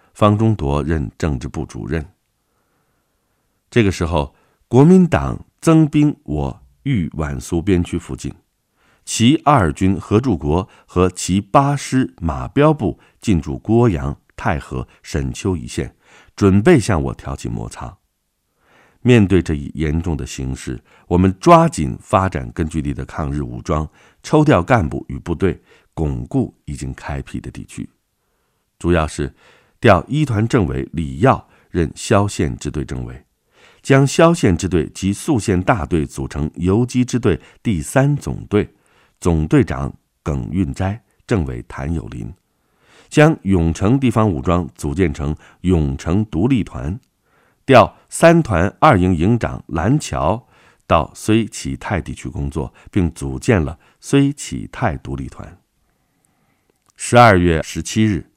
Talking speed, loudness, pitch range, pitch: 195 characters per minute, -17 LUFS, 75-115 Hz, 90 Hz